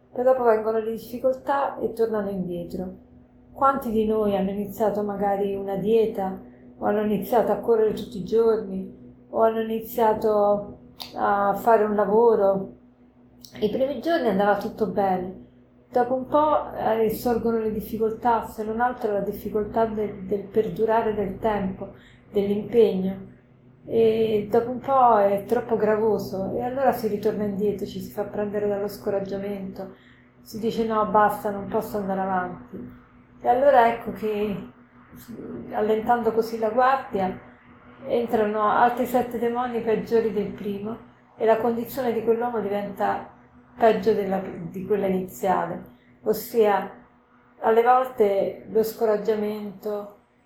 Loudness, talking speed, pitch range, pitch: -24 LUFS, 130 wpm, 200-225 Hz, 215 Hz